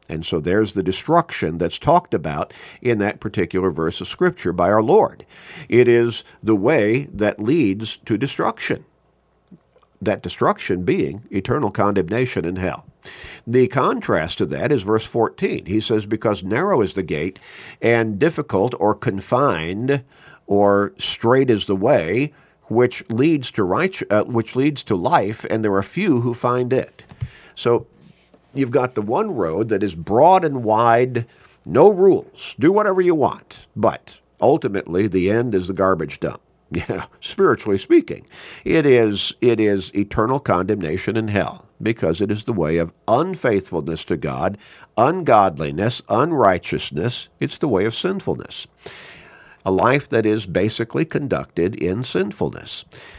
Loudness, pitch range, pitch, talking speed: -19 LUFS, 95-125 Hz, 110 Hz, 145 wpm